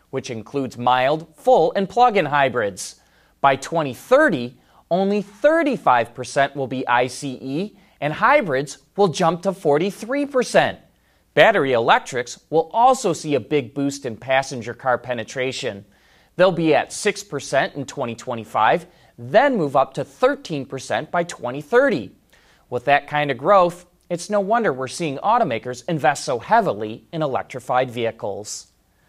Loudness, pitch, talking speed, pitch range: -20 LUFS, 145 Hz, 130 wpm, 130-185 Hz